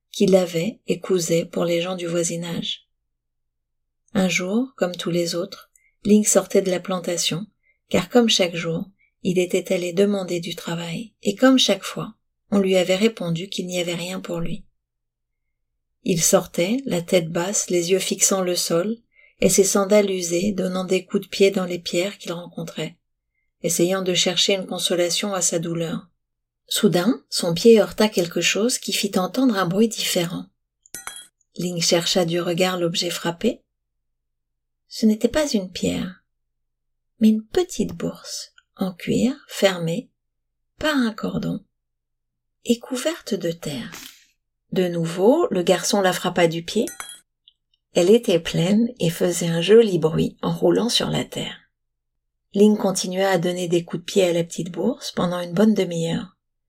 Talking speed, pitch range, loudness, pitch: 160 wpm, 170-205 Hz, -21 LUFS, 185 Hz